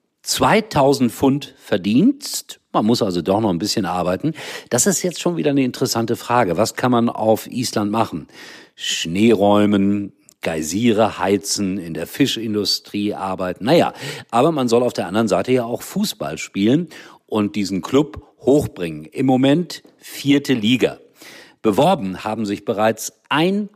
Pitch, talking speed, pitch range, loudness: 115 Hz, 145 wpm, 100-140 Hz, -19 LUFS